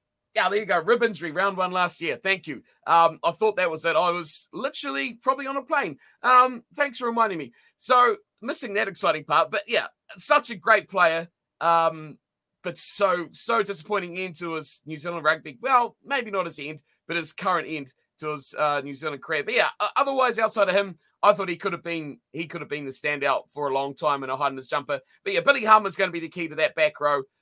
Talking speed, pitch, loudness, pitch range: 235 wpm, 175 Hz, -24 LUFS, 155-225 Hz